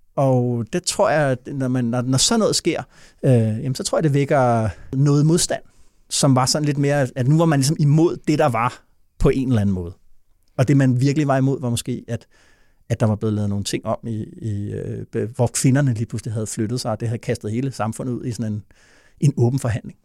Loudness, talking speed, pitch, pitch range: -20 LUFS, 240 wpm, 125 Hz, 115-140 Hz